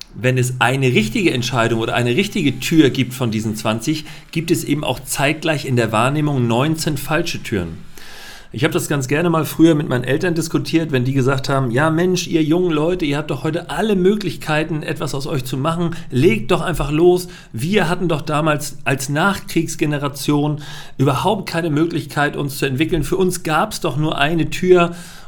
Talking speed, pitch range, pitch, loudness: 190 wpm, 135-165 Hz, 155 Hz, -18 LUFS